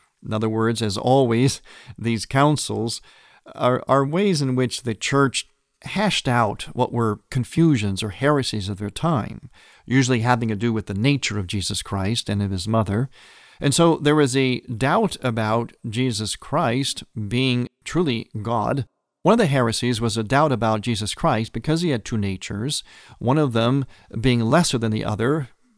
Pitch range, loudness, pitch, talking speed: 110-135 Hz, -22 LUFS, 120 Hz, 170 wpm